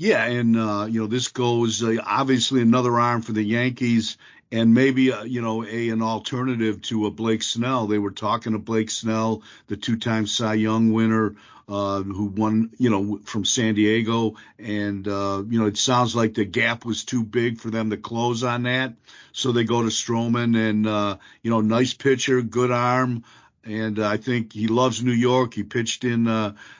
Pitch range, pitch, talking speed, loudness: 110-120 Hz, 115 Hz, 195 wpm, -22 LUFS